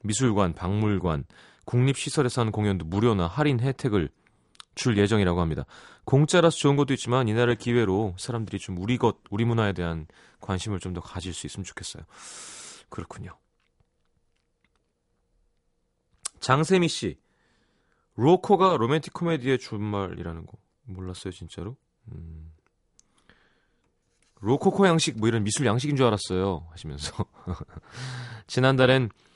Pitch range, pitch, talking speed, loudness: 95-130 Hz, 110 Hz, 285 characters per minute, -25 LUFS